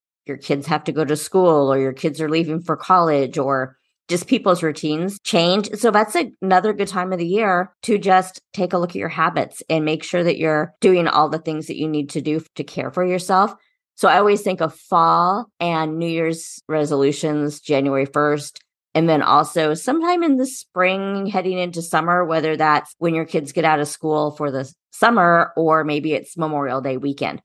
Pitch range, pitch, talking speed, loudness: 150-185 Hz, 160 Hz, 205 wpm, -19 LUFS